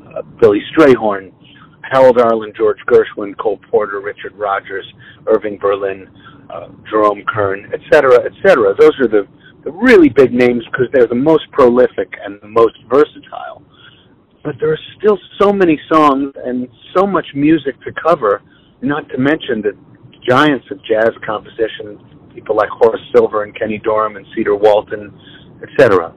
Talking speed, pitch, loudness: 150 wpm, 165 Hz, -13 LUFS